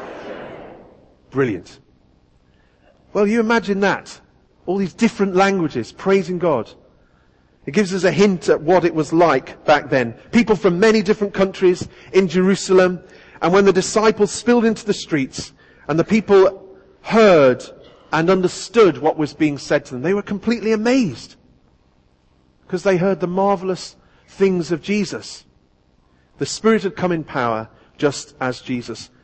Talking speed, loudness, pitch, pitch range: 145 wpm, -18 LUFS, 185 Hz, 140-200 Hz